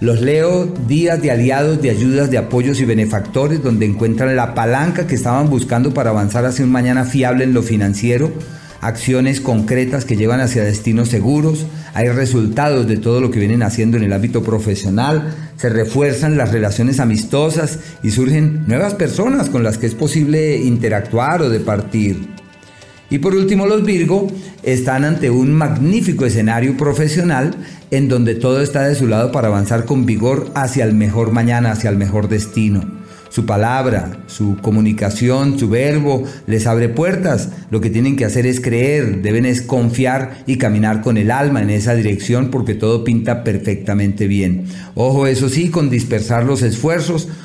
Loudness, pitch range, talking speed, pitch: -15 LUFS, 110-145 Hz, 170 wpm, 125 Hz